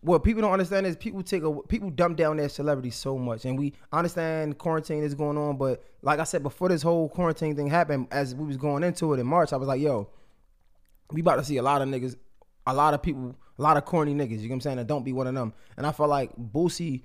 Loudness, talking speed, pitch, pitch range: -27 LUFS, 275 wpm, 145 Hz, 130-165 Hz